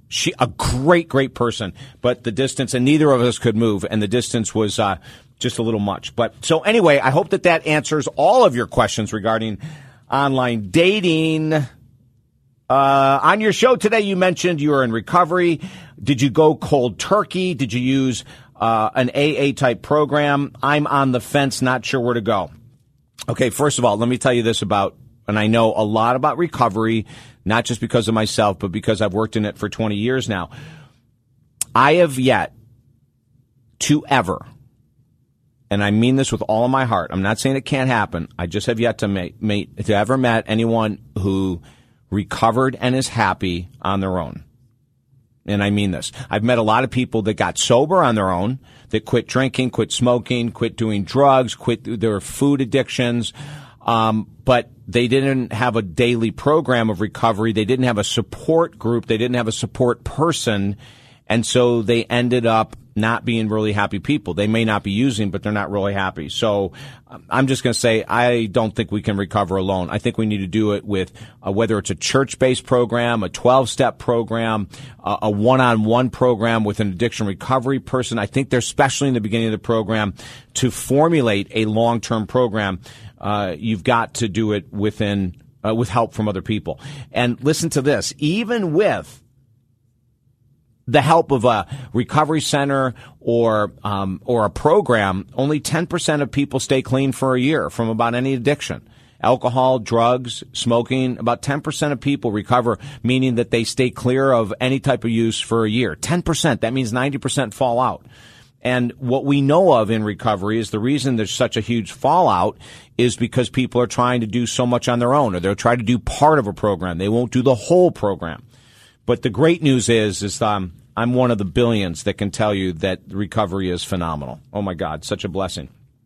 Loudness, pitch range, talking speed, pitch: -19 LUFS, 110-130 Hz, 195 wpm, 120 Hz